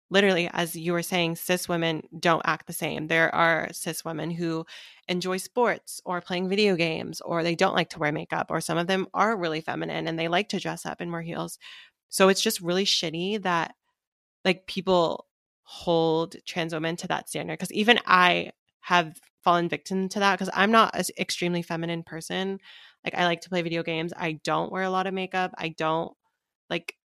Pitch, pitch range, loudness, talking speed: 175 Hz, 165-185 Hz, -26 LUFS, 200 wpm